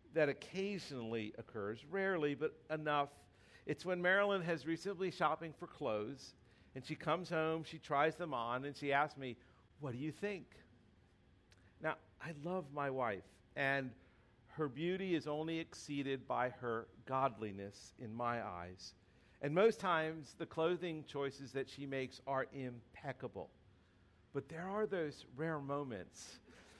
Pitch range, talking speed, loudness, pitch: 115-160 Hz, 145 wpm, -41 LUFS, 140 Hz